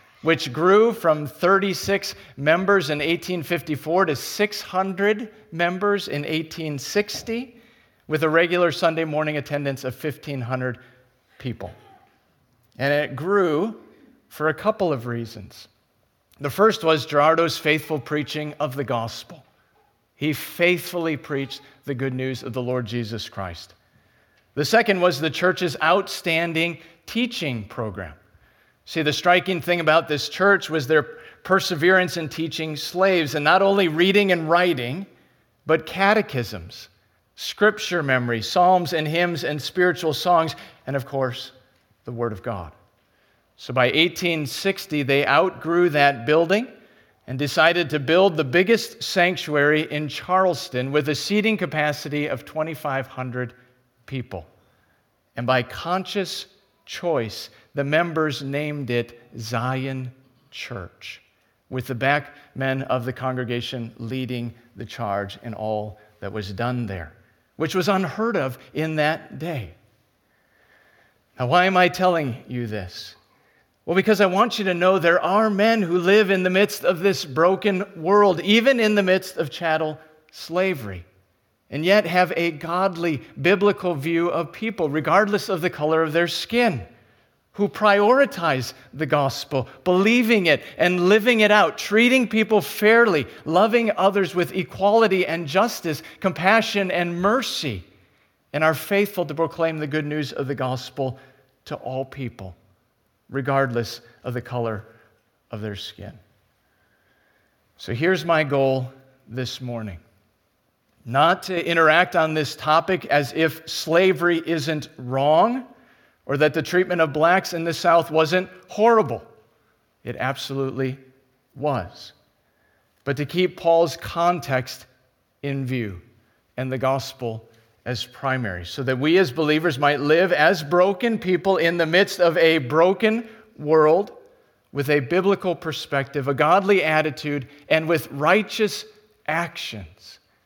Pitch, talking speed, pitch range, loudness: 155 Hz, 135 wpm, 130-180 Hz, -21 LUFS